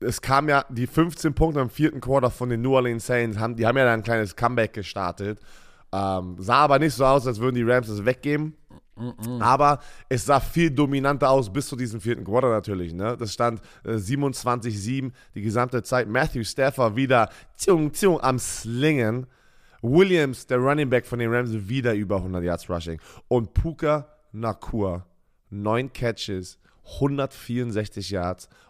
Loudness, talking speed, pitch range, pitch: -24 LUFS, 170 wpm, 110-135 Hz, 120 Hz